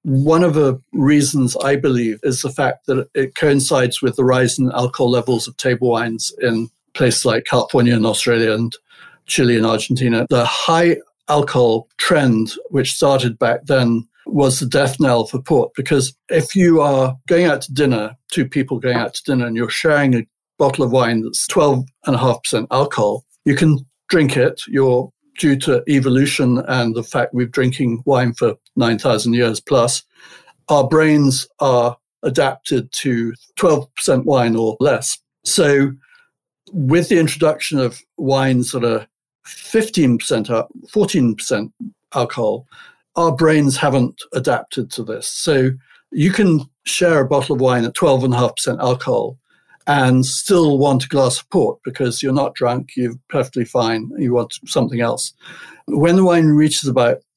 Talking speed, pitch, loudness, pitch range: 155 wpm, 130 Hz, -16 LUFS, 120-145 Hz